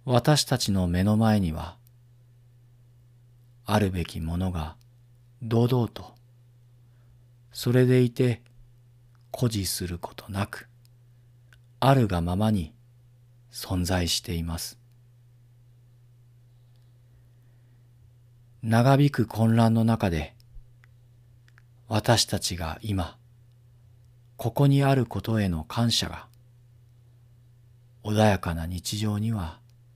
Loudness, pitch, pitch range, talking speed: -25 LUFS, 120 Hz, 105-120 Hz, 155 characters per minute